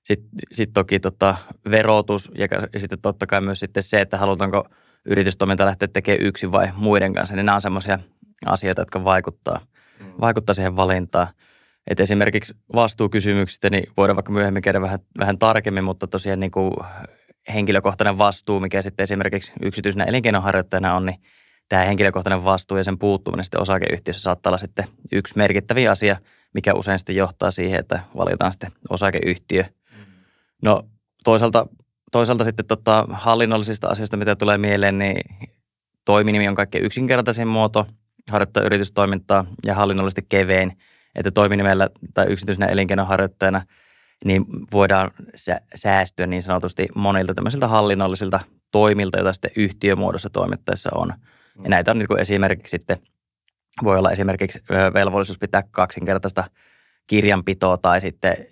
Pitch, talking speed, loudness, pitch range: 100 Hz, 135 wpm, -20 LUFS, 95-105 Hz